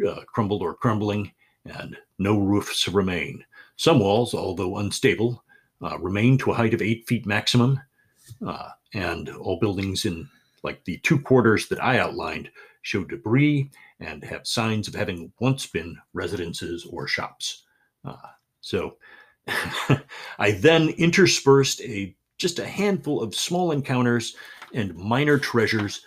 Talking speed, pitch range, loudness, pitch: 140 wpm, 100-135 Hz, -23 LUFS, 115 Hz